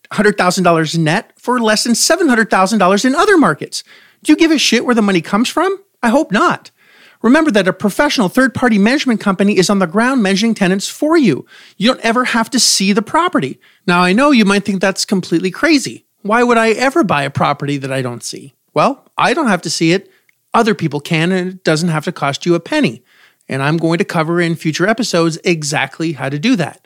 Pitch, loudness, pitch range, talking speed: 205 Hz, -13 LUFS, 170-245 Hz, 220 wpm